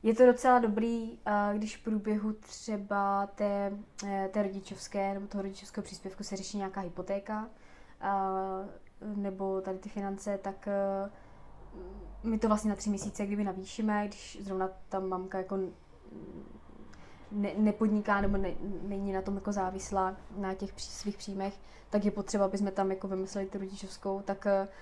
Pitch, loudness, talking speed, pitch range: 200 Hz, -33 LUFS, 145 wpm, 195-205 Hz